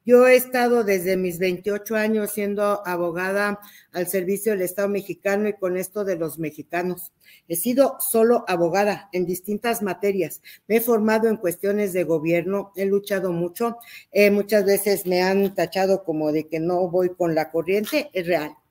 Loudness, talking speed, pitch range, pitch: -22 LUFS, 170 wpm, 180-210 Hz, 195 Hz